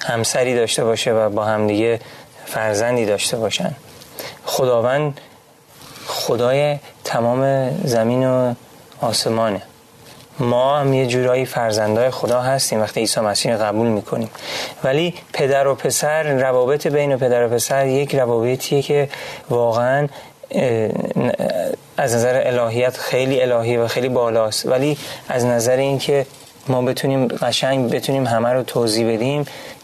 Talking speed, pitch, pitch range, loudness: 125 wpm, 125 Hz, 115-135 Hz, -18 LUFS